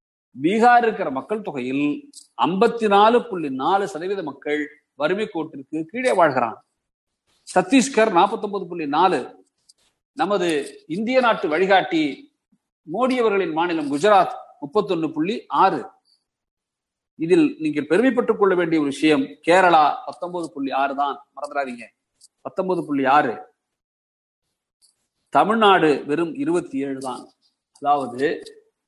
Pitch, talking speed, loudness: 195 Hz, 110 wpm, -20 LUFS